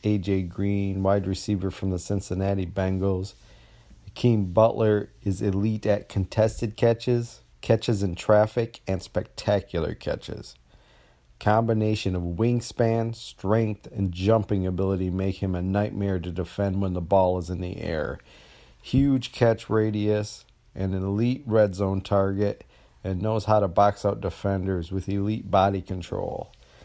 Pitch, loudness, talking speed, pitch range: 100 Hz, -25 LUFS, 135 wpm, 95-110 Hz